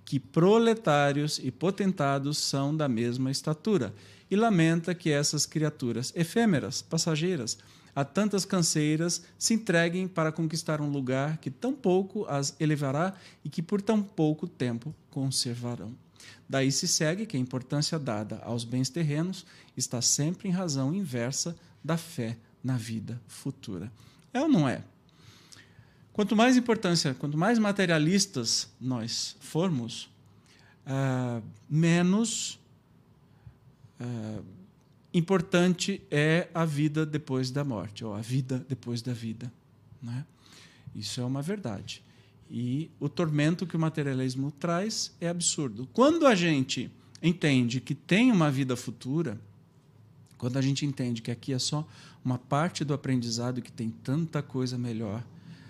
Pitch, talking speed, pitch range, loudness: 145 Hz, 130 wpm, 125-170 Hz, -29 LUFS